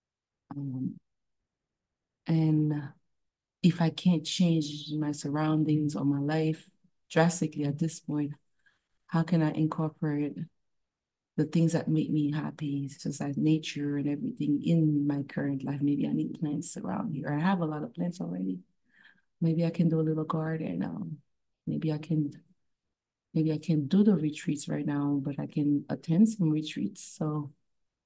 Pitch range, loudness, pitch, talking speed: 145-165 Hz, -30 LUFS, 155 Hz, 160 wpm